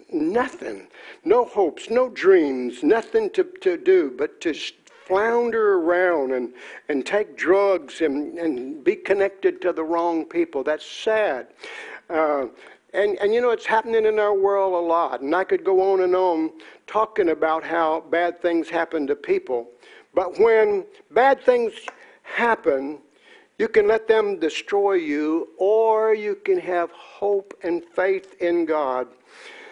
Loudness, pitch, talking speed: -22 LUFS, 200 Hz, 150 wpm